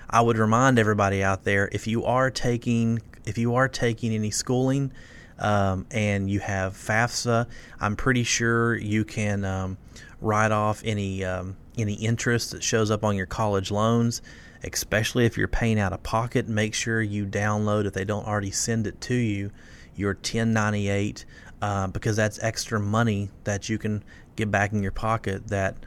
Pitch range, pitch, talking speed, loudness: 100-115 Hz, 105 Hz, 175 wpm, -25 LUFS